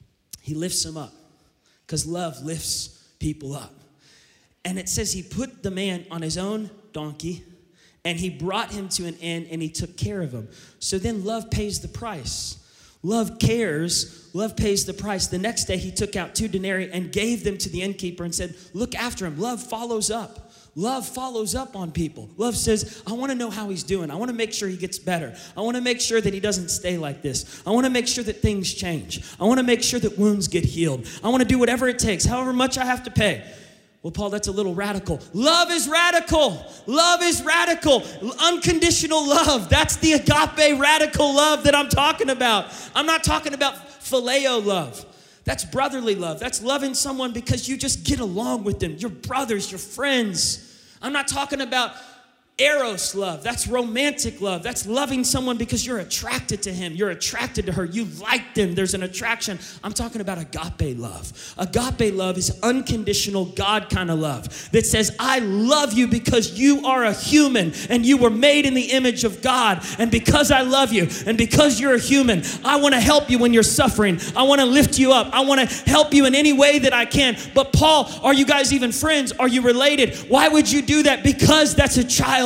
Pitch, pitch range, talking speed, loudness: 225 Hz, 185-265 Hz, 210 wpm, -20 LUFS